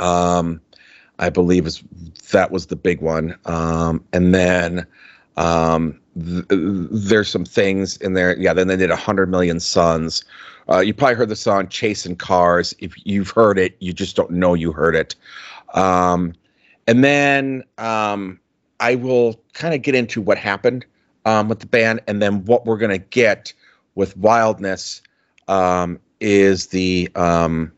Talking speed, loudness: 165 wpm, -18 LUFS